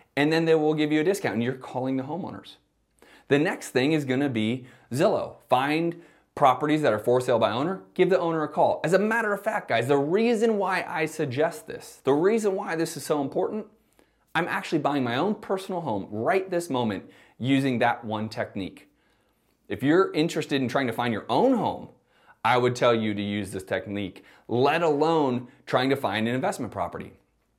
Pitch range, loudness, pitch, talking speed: 125-170 Hz, -25 LUFS, 150 Hz, 200 wpm